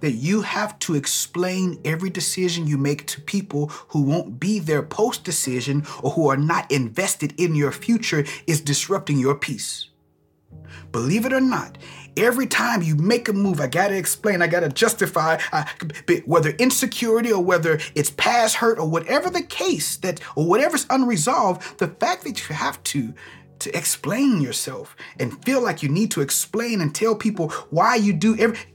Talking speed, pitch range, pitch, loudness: 180 wpm, 145-220 Hz, 175 Hz, -21 LUFS